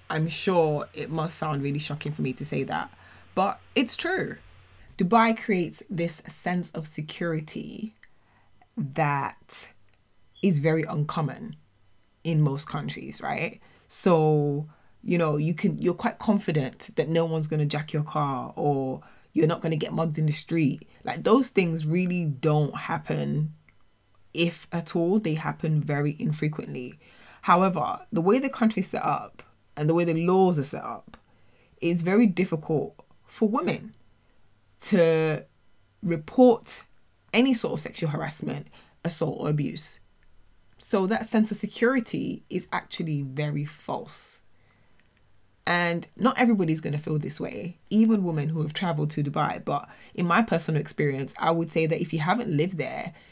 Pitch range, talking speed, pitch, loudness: 145-180 Hz, 150 wpm, 160 Hz, -26 LUFS